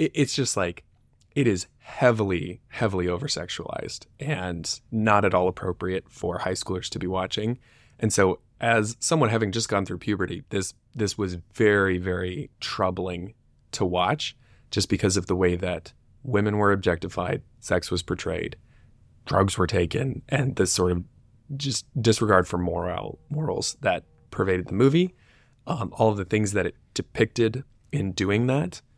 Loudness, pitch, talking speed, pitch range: -25 LUFS, 100 Hz, 155 wpm, 90-115 Hz